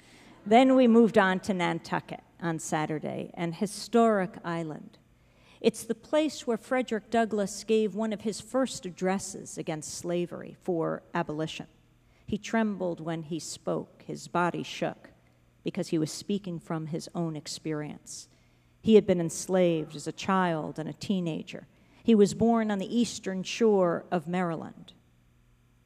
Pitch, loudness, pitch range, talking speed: 180 Hz, -29 LUFS, 160-210 Hz, 145 wpm